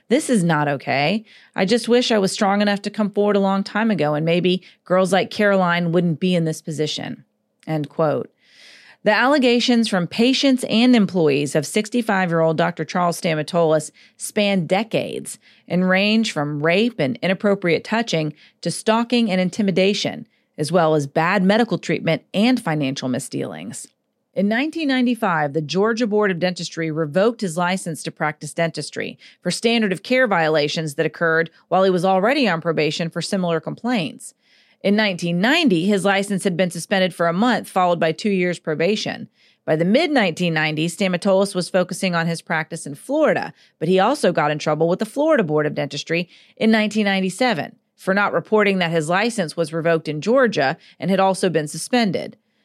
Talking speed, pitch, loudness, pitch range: 170 wpm, 185 Hz, -19 LUFS, 165-215 Hz